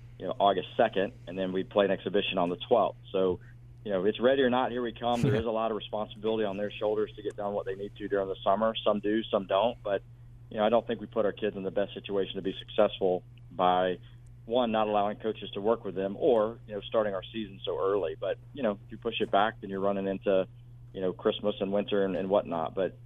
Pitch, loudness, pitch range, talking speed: 105 Hz, -30 LUFS, 100-120 Hz, 265 wpm